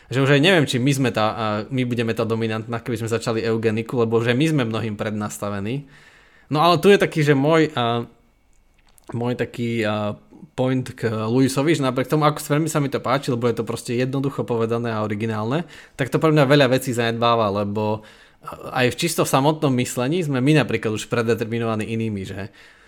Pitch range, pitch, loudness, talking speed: 115-140 Hz, 120 Hz, -21 LUFS, 185 wpm